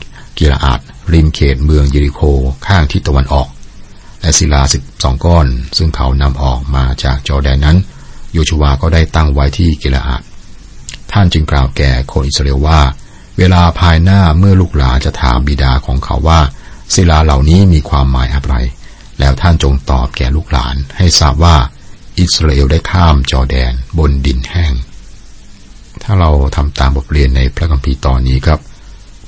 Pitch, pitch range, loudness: 75 Hz, 65-85 Hz, -11 LUFS